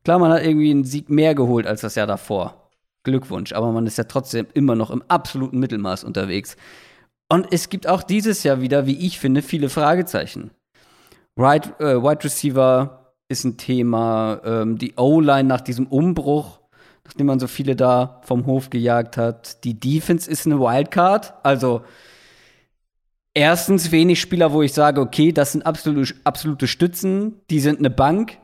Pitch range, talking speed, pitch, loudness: 125-160 Hz, 165 wpm, 140 Hz, -19 LUFS